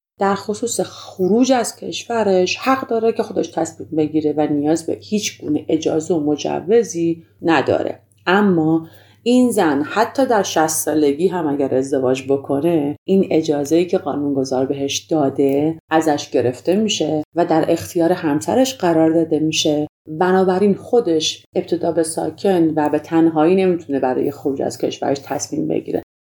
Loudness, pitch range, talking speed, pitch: -18 LUFS, 150-190 Hz, 140 wpm, 165 Hz